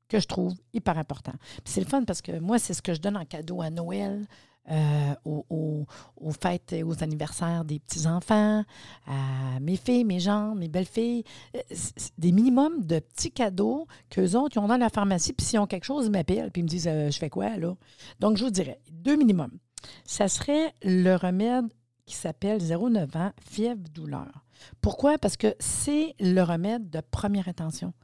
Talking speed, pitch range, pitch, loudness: 195 wpm, 155-215 Hz, 180 Hz, -27 LUFS